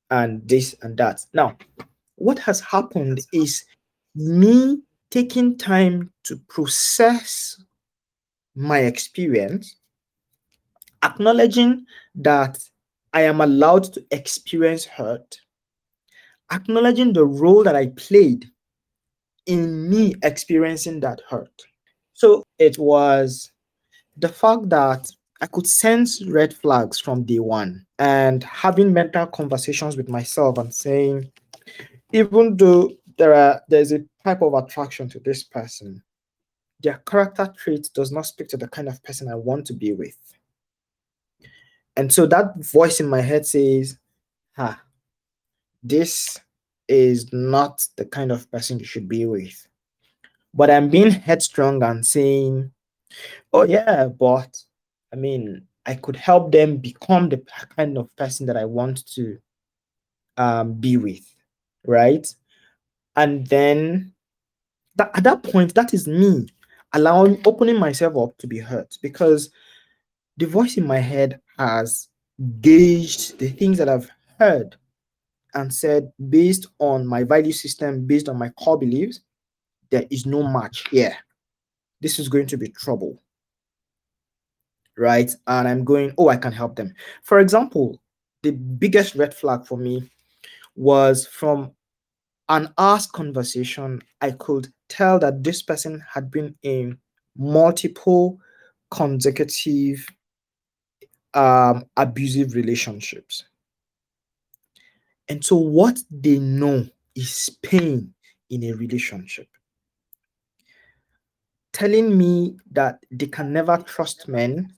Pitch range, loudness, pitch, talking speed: 130-170 Hz, -18 LUFS, 145 Hz, 125 wpm